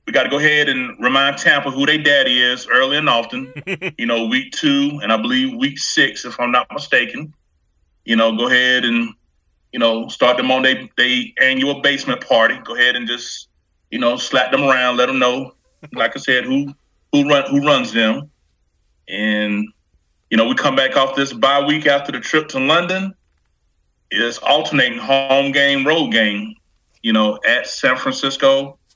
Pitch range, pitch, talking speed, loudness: 115-140 Hz, 130 Hz, 185 wpm, -16 LUFS